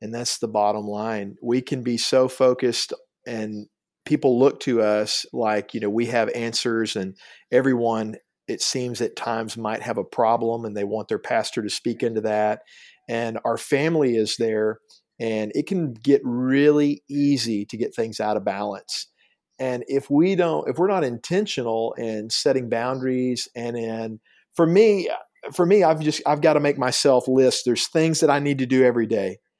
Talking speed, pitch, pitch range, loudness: 185 wpm, 120 Hz, 115-140 Hz, -22 LUFS